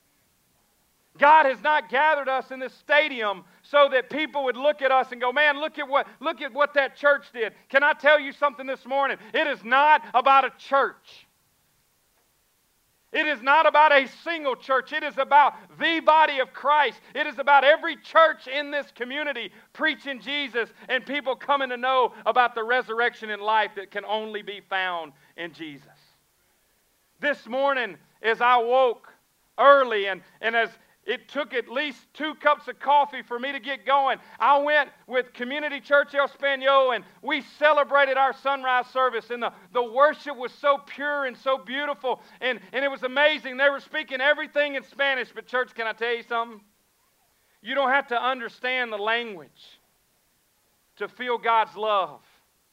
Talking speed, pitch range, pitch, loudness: 175 wpm, 235-285 Hz, 265 Hz, -23 LUFS